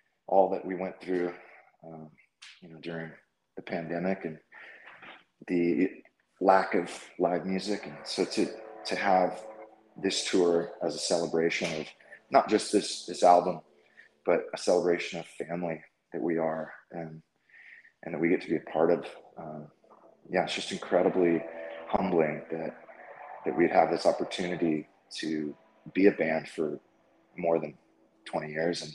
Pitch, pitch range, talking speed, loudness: 85 Hz, 80-95 Hz, 150 wpm, -29 LUFS